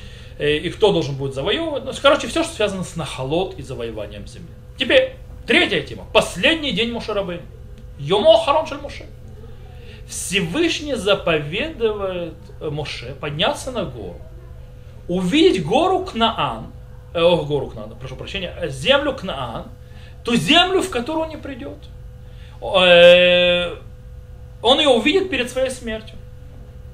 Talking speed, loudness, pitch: 120 wpm, -18 LUFS, 195 Hz